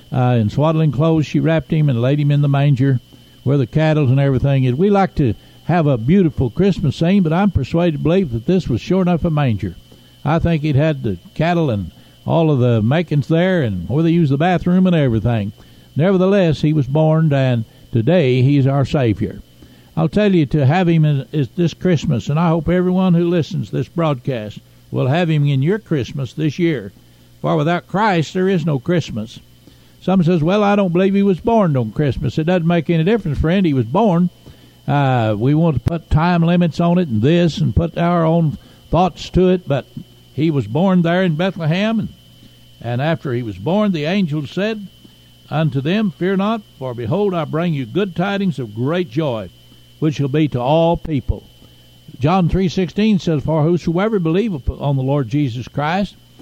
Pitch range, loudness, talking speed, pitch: 130-175 Hz, -17 LUFS, 200 wpm, 155 Hz